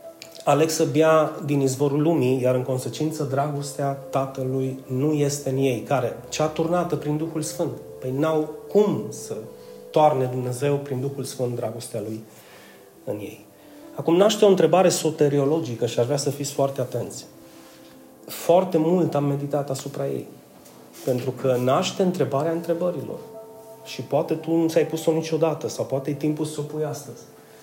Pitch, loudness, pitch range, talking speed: 145 Hz, -23 LUFS, 130-160 Hz, 155 wpm